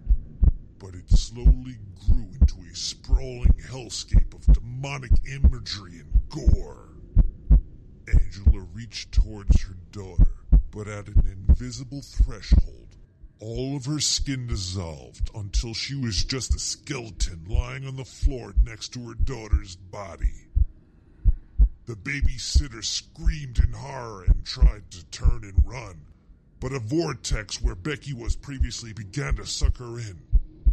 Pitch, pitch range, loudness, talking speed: 95 Hz, 80-120 Hz, -27 LUFS, 130 wpm